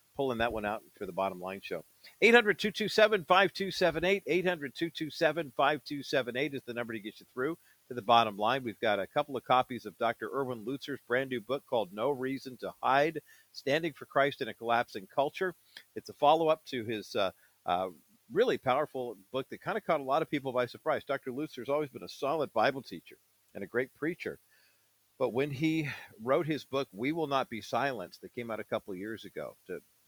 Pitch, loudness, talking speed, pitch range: 135 Hz, -32 LUFS, 195 wpm, 120-155 Hz